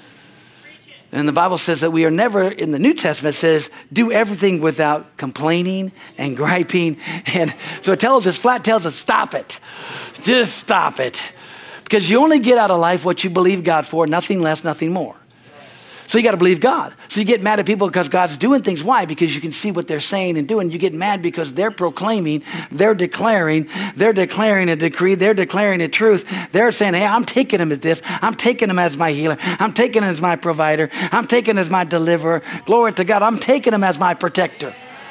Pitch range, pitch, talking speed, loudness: 165-215 Hz, 185 Hz, 215 wpm, -17 LUFS